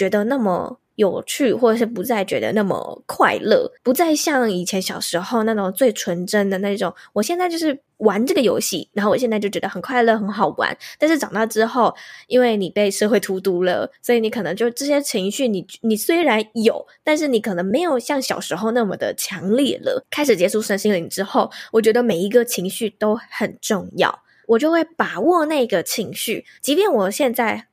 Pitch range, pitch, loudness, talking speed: 200-265 Hz, 225 Hz, -19 LUFS, 305 characters per minute